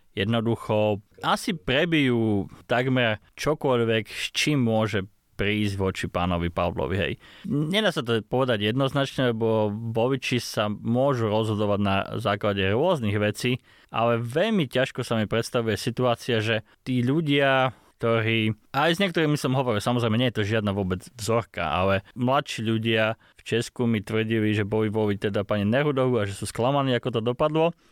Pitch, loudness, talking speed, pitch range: 115 Hz, -25 LUFS, 145 wpm, 105-130 Hz